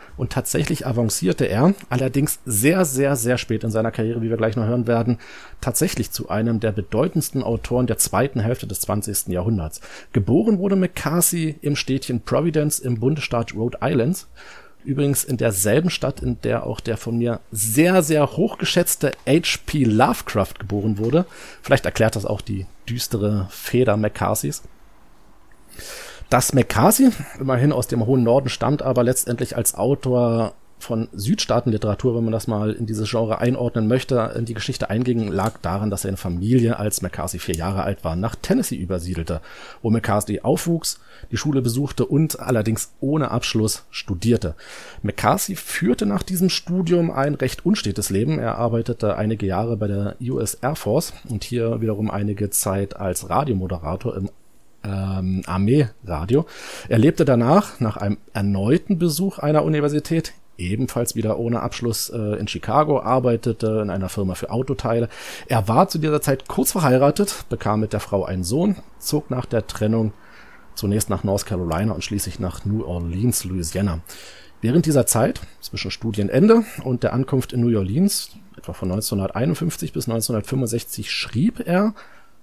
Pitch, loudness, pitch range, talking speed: 115 Hz, -21 LUFS, 105-135 Hz, 155 wpm